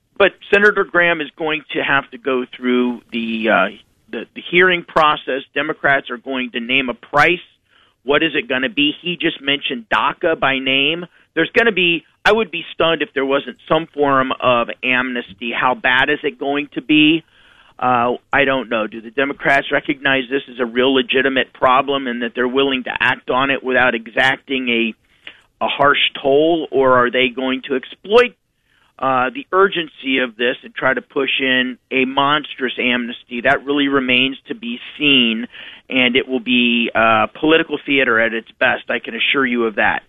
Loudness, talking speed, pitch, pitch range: -16 LUFS, 190 wpm, 135 Hz, 125-150 Hz